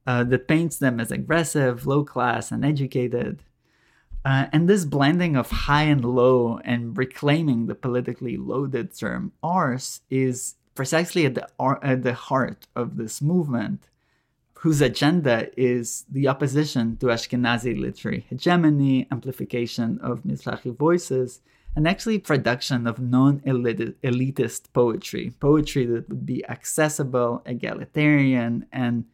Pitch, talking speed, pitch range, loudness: 130 Hz, 125 wpm, 120-145 Hz, -23 LUFS